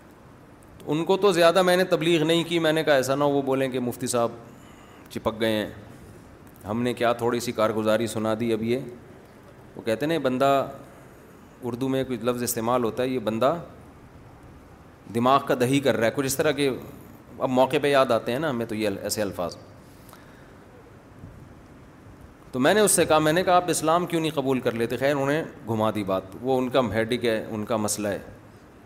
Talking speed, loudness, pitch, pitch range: 210 wpm, -24 LUFS, 125 Hz, 110-140 Hz